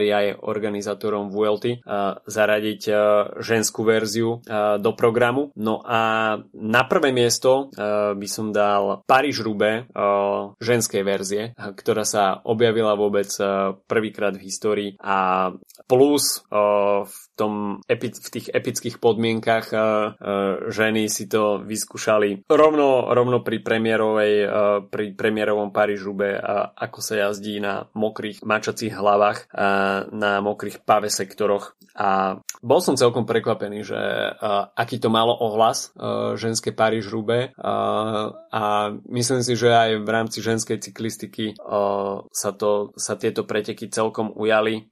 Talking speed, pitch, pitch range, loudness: 120 wpm, 105 Hz, 100-115 Hz, -22 LUFS